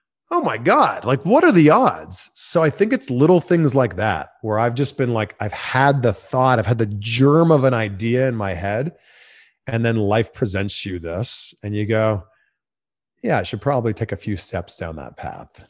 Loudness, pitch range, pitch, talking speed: -19 LUFS, 105-135 Hz, 115 Hz, 210 wpm